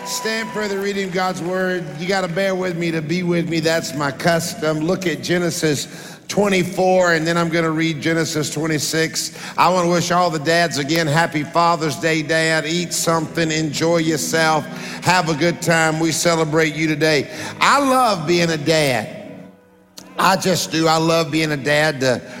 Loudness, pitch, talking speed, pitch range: -18 LUFS, 165 Hz, 185 wpm, 160-175 Hz